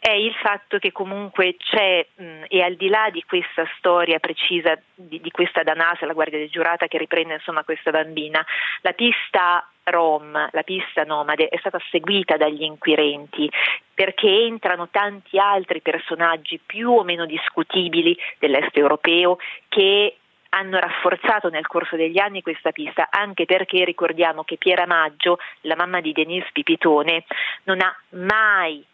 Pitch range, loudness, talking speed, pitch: 160-195 Hz, -20 LUFS, 150 wpm, 175 Hz